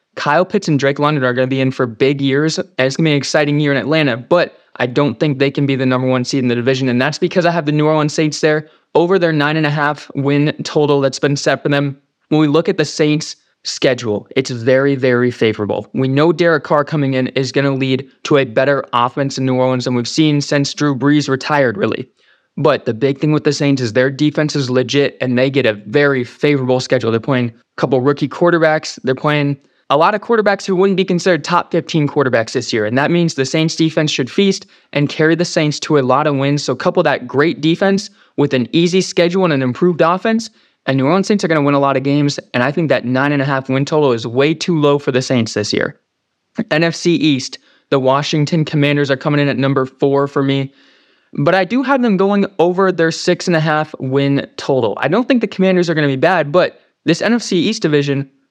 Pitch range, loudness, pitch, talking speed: 135-160 Hz, -15 LUFS, 145 Hz, 245 wpm